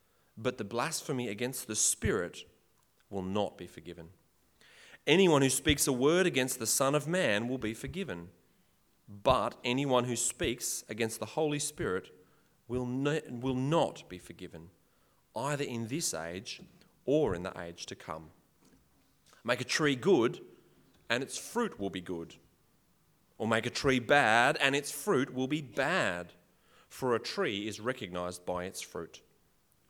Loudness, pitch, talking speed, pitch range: -31 LUFS, 120 Hz, 150 wpm, 95-140 Hz